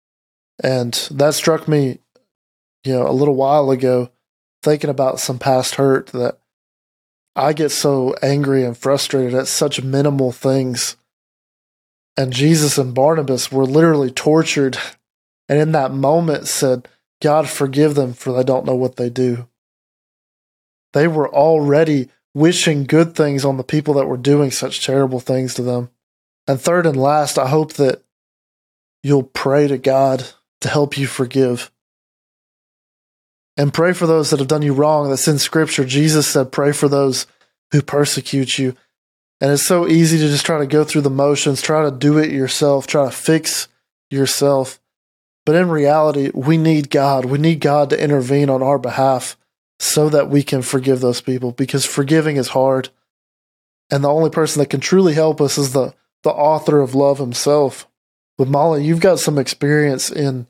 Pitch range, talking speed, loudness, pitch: 130-150 Hz, 170 wpm, -16 LUFS, 140 Hz